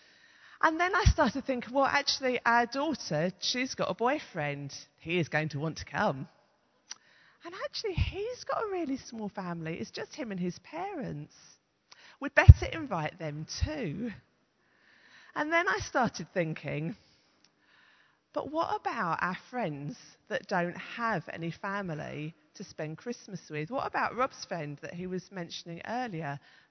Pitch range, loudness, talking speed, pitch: 160-255 Hz, -31 LUFS, 150 wpm, 185 Hz